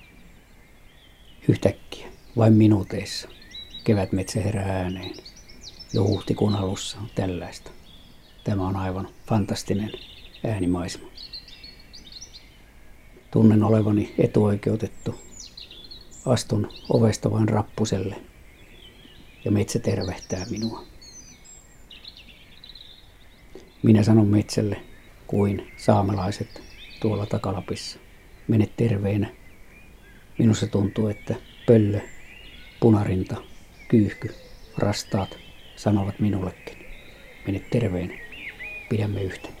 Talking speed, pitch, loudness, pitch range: 75 wpm, 105 Hz, -24 LUFS, 95-110 Hz